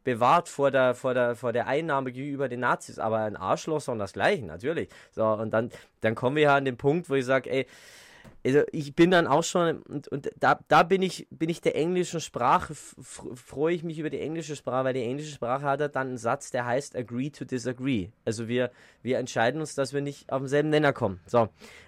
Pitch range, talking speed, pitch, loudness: 120-150 Hz, 235 wpm, 135 Hz, -27 LUFS